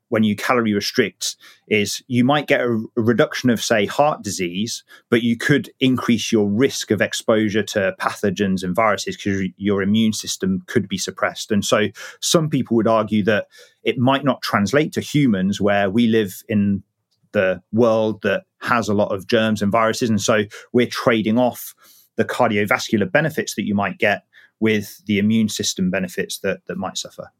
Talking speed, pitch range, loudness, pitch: 175 wpm, 100-120 Hz, -19 LUFS, 110 Hz